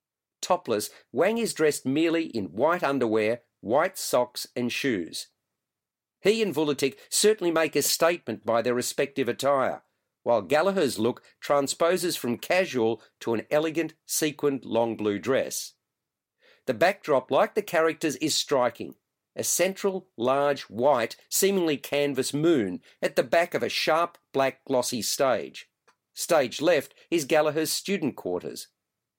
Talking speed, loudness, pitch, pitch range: 135 wpm, -26 LUFS, 150 Hz, 125-170 Hz